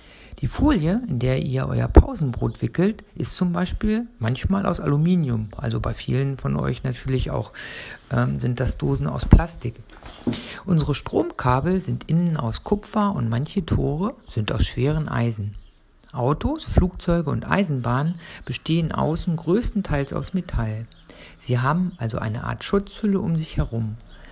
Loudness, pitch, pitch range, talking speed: -23 LUFS, 140 Hz, 115-180 Hz, 145 wpm